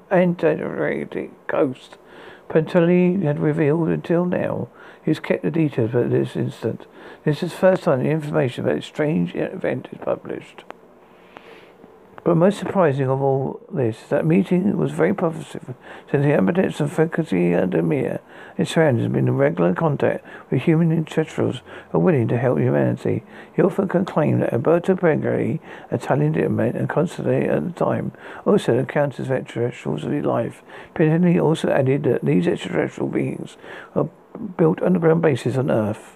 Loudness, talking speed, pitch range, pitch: -21 LUFS, 160 wpm, 130-175 Hz, 160 Hz